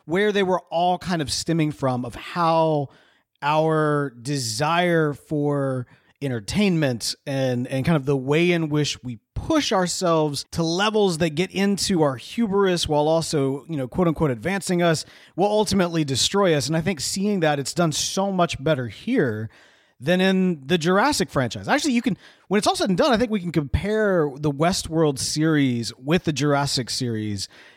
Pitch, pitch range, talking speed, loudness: 160 Hz, 140-185 Hz, 175 wpm, -22 LUFS